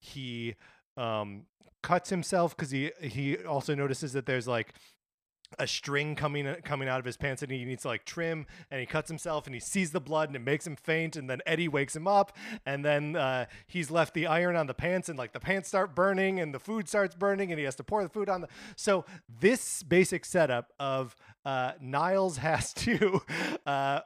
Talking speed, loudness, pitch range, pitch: 215 wpm, -31 LUFS, 135-180 Hz, 155 Hz